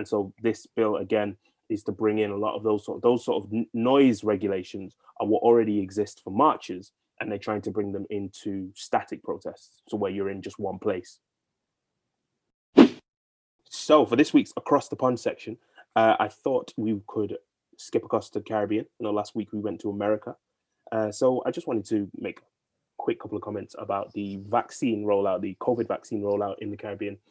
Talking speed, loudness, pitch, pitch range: 200 wpm, -27 LUFS, 105 Hz, 100-115 Hz